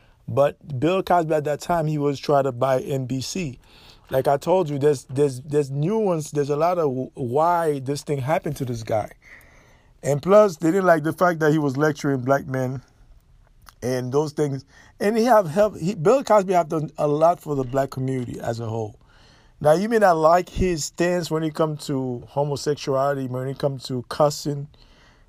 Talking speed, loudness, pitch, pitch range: 195 wpm, -22 LUFS, 145 Hz, 135-165 Hz